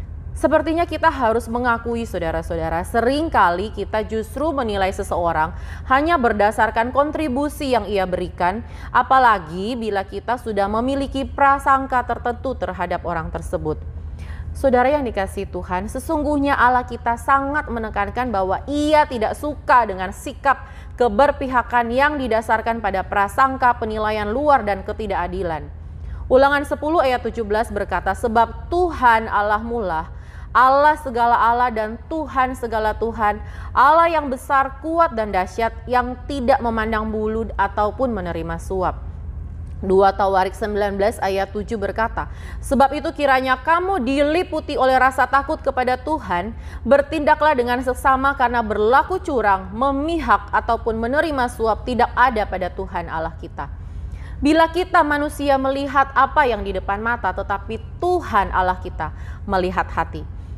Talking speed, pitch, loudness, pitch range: 125 wpm, 235 Hz, -19 LUFS, 200-275 Hz